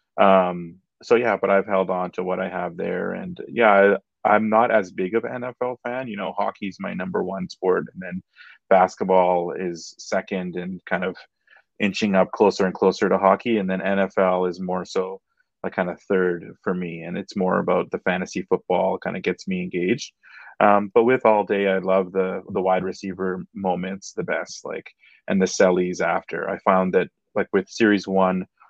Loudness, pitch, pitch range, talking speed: -22 LUFS, 95 Hz, 90-100 Hz, 200 wpm